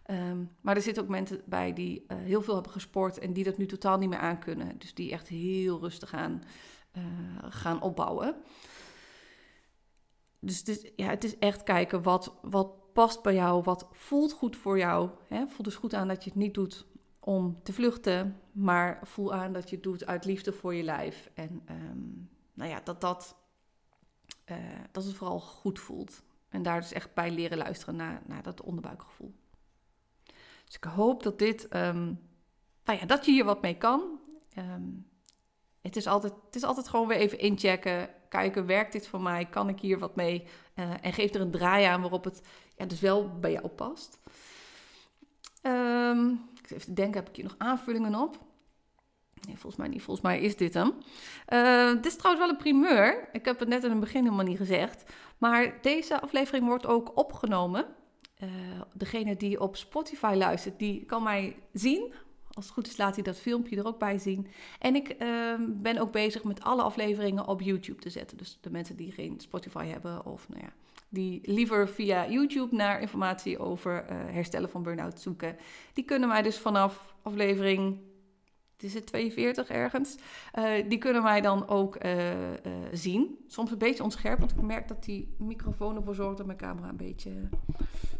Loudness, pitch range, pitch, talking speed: -31 LUFS, 180-230 Hz, 200 Hz, 190 wpm